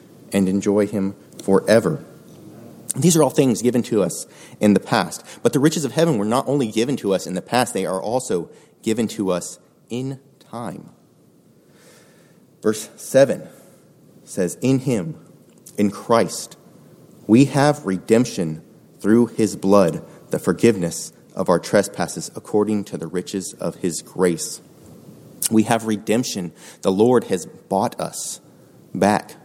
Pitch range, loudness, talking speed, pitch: 95-125 Hz, -20 LUFS, 145 wpm, 110 Hz